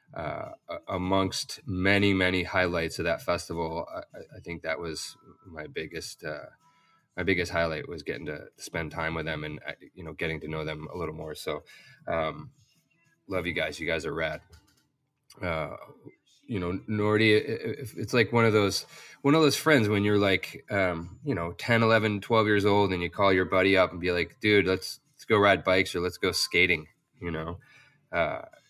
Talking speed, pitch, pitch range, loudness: 190 wpm, 100 Hz, 85-120 Hz, -27 LUFS